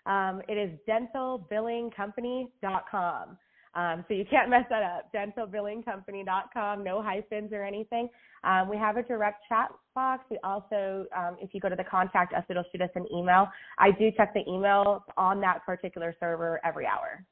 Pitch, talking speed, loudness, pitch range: 200 Hz, 170 wpm, -29 LUFS, 185-220 Hz